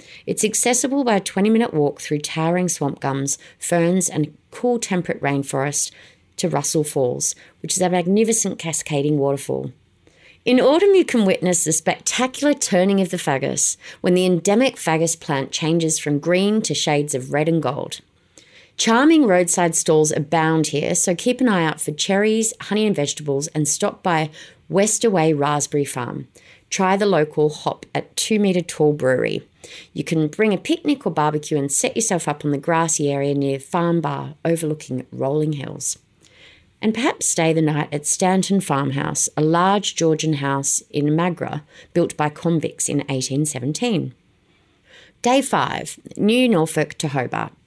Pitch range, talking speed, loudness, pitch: 150-195 Hz, 155 wpm, -19 LUFS, 165 Hz